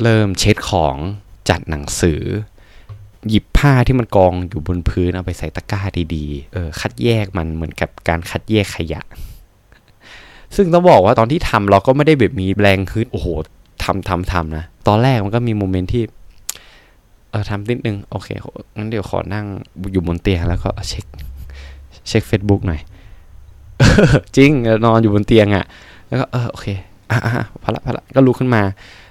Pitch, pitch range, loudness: 100 Hz, 90-110 Hz, -16 LUFS